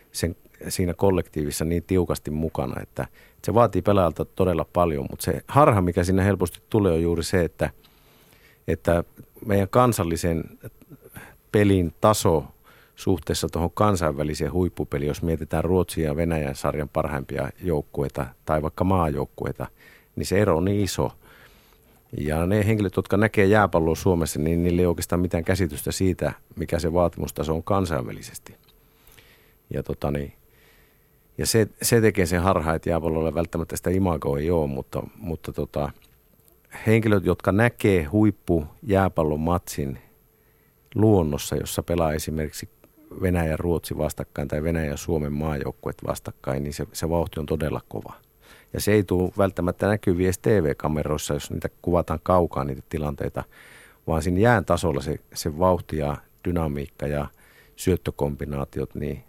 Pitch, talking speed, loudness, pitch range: 85 Hz, 140 wpm, -24 LUFS, 75-95 Hz